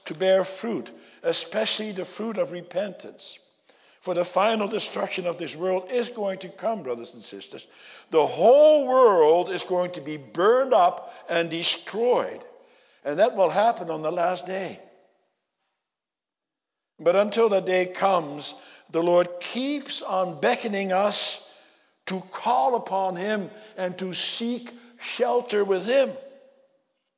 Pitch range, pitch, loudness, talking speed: 180-245 Hz, 195 Hz, -24 LUFS, 135 wpm